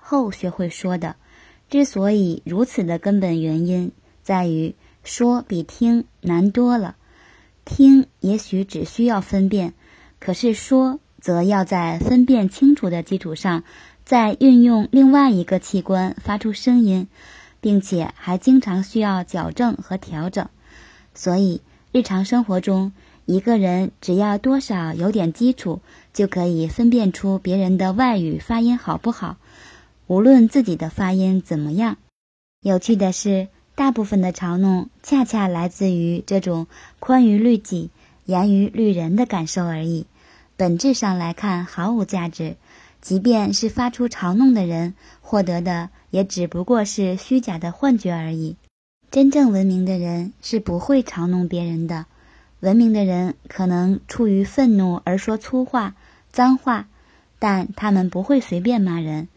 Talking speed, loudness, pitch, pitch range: 220 characters per minute, -19 LUFS, 195 Hz, 180-235 Hz